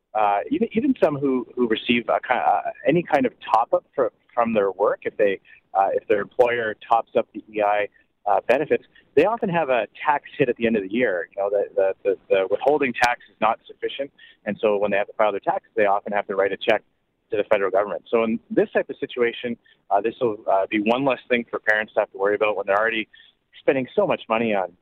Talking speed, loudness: 245 wpm, -22 LUFS